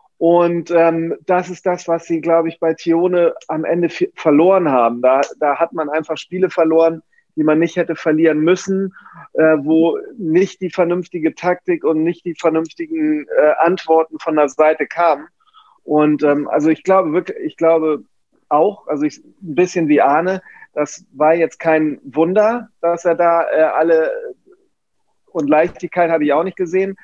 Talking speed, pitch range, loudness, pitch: 170 wpm, 160-185 Hz, -16 LUFS, 170 Hz